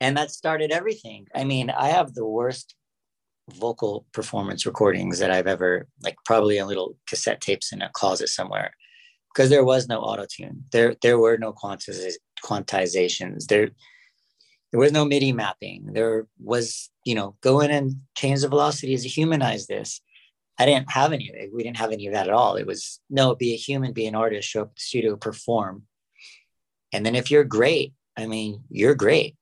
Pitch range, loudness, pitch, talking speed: 110-145 Hz, -23 LUFS, 125 Hz, 185 wpm